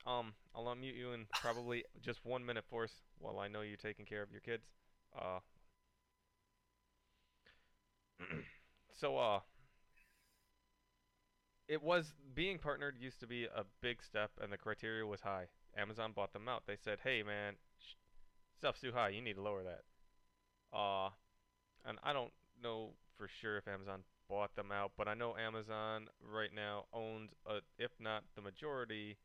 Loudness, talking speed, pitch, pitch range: -45 LUFS, 160 wpm, 110 Hz, 100-120 Hz